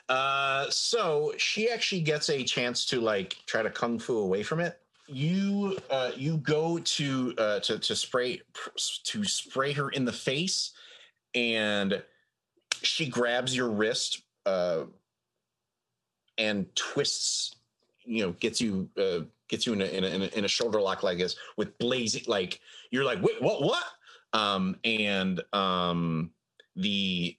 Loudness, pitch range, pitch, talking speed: -29 LUFS, 100-170 Hz, 125 Hz, 150 wpm